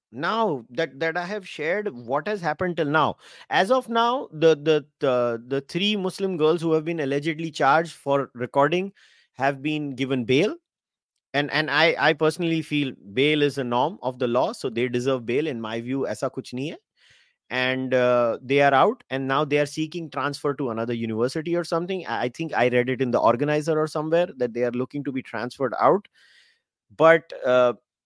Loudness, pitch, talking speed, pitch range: -23 LUFS, 145 Hz, 195 wpm, 125-165 Hz